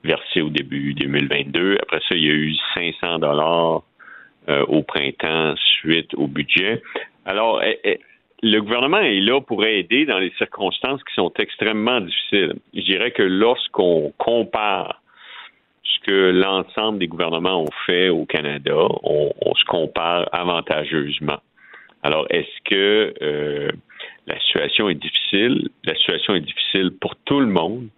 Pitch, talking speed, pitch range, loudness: 85 Hz, 140 wpm, 75-110 Hz, -19 LUFS